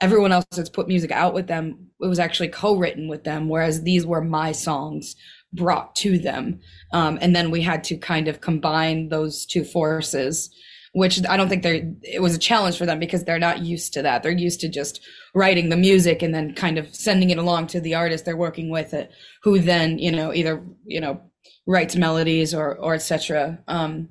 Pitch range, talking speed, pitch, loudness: 160-175 Hz, 215 wpm, 165 Hz, -21 LUFS